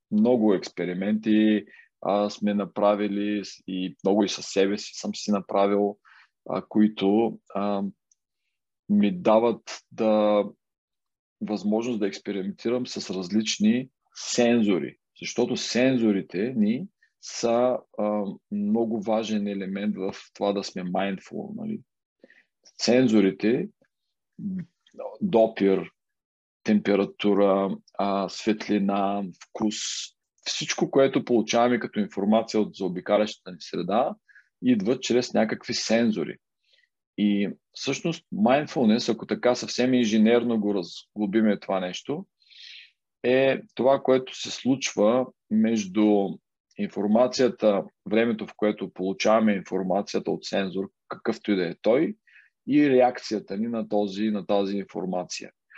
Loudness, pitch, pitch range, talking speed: -25 LUFS, 105 Hz, 100-125 Hz, 105 wpm